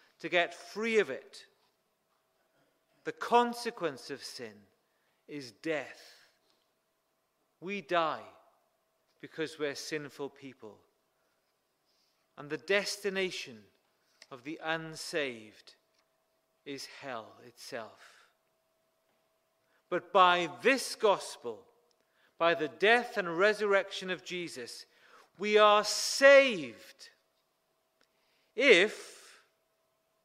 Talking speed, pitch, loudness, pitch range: 80 wpm, 175 Hz, -29 LUFS, 155-210 Hz